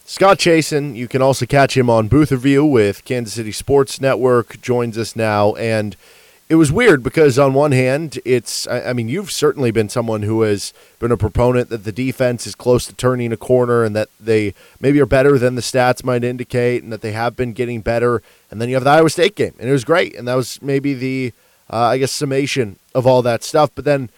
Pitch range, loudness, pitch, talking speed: 115-135 Hz, -16 LUFS, 125 Hz, 230 wpm